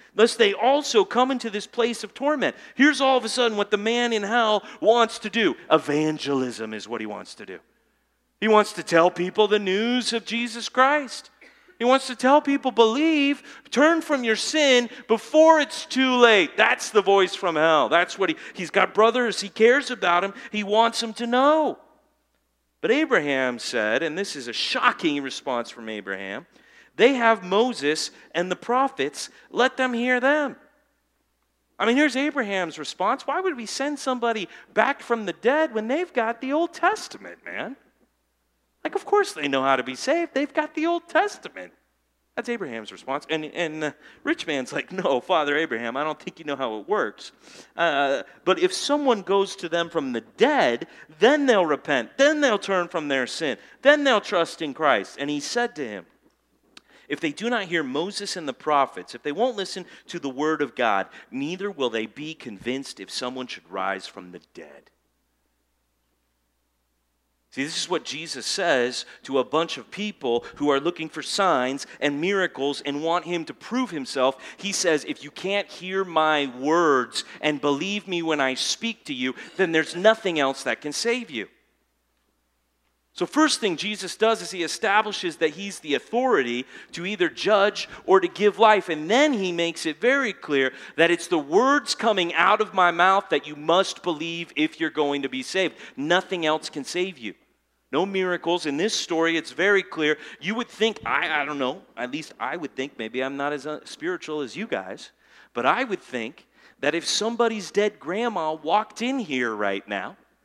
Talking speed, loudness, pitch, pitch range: 190 wpm, -23 LUFS, 195 Hz, 150-245 Hz